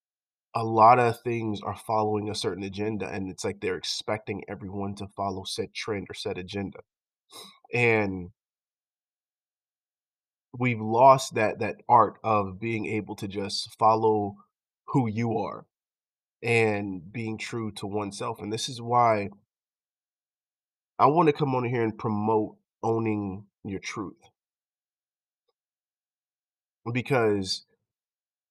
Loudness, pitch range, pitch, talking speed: -27 LUFS, 100-115 Hz, 110 Hz, 120 wpm